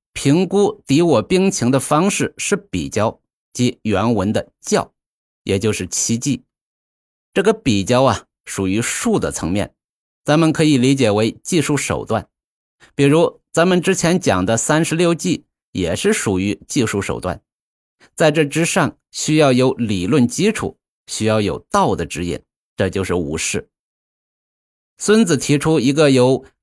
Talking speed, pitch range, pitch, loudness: 210 characters per minute, 110-165 Hz, 140 Hz, -17 LUFS